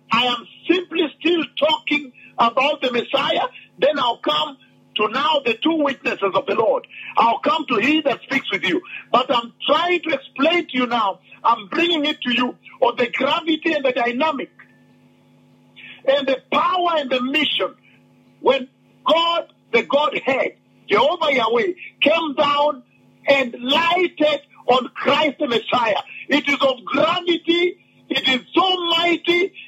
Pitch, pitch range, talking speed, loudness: 295 Hz, 260-330 Hz, 150 wpm, -19 LUFS